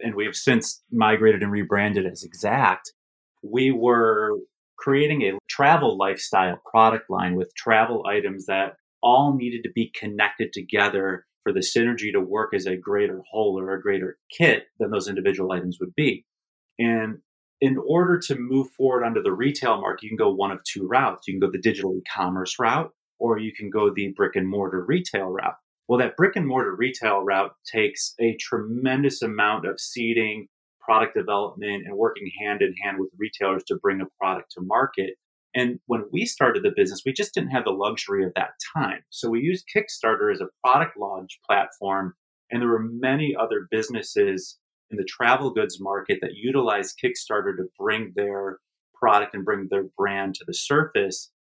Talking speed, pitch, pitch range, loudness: 185 wpm, 115 Hz, 100-140 Hz, -23 LUFS